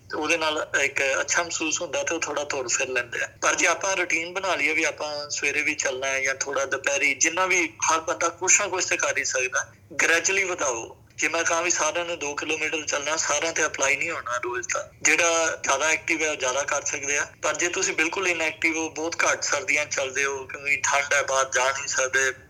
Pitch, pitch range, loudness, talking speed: 160 Hz, 145-170 Hz, -23 LUFS, 215 wpm